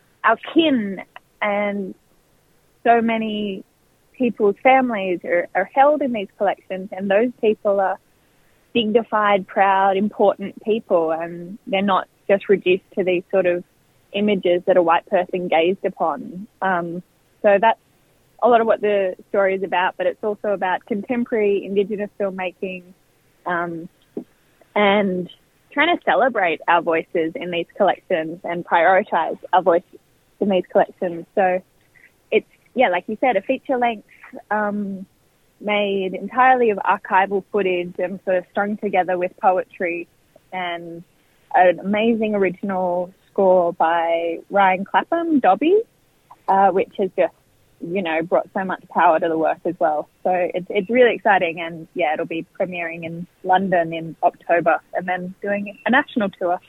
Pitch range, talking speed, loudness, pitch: 175-210 Hz, 145 wpm, -20 LUFS, 190 Hz